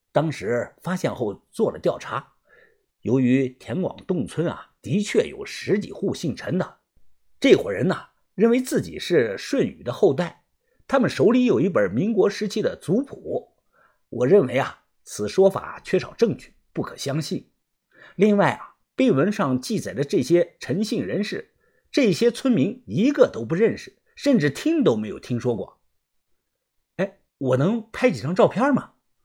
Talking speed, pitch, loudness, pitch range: 230 characters per minute, 210 Hz, -23 LUFS, 170-255 Hz